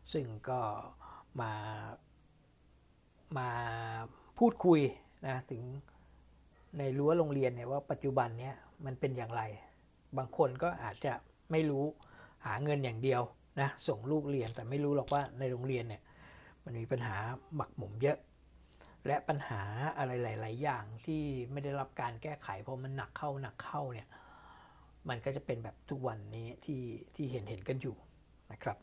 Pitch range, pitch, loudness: 115-140 Hz, 130 Hz, -37 LUFS